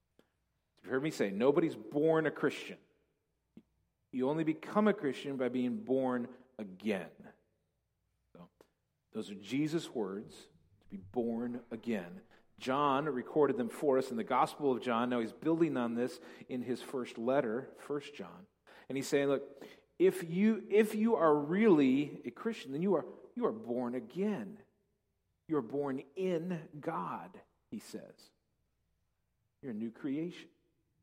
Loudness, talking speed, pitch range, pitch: -34 LUFS, 145 wpm, 125-175 Hz, 140 Hz